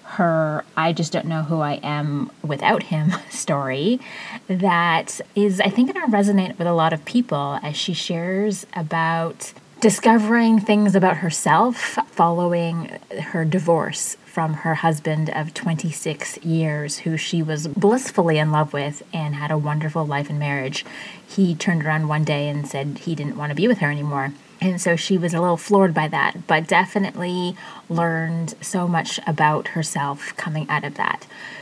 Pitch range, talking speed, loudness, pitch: 155-185 Hz, 165 wpm, -21 LUFS, 165 Hz